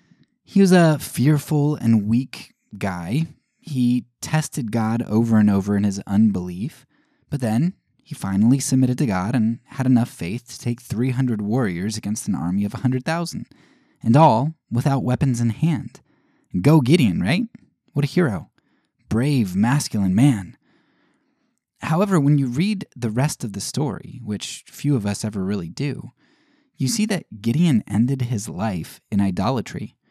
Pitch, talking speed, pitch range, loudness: 130 Hz, 150 wpm, 110-155 Hz, -21 LUFS